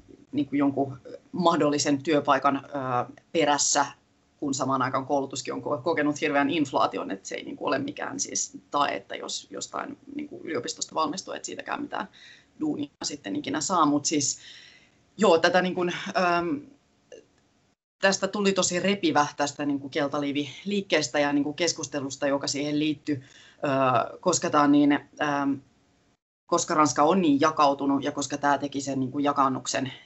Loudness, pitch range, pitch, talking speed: -26 LUFS, 140-180 Hz, 145 Hz, 150 wpm